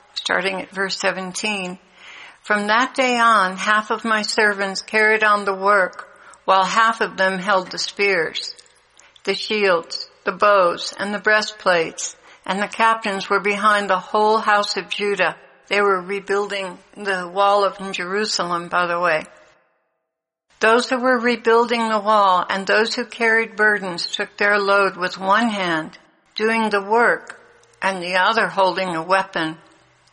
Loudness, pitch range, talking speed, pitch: -19 LUFS, 190-220 Hz, 150 wpm, 205 Hz